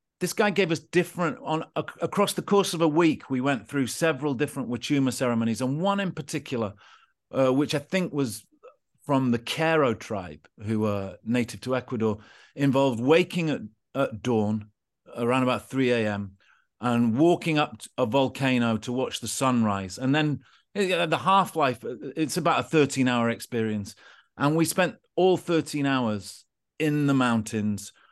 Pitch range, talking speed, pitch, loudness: 115-160 Hz, 155 wpm, 135 Hz, -26 LUFS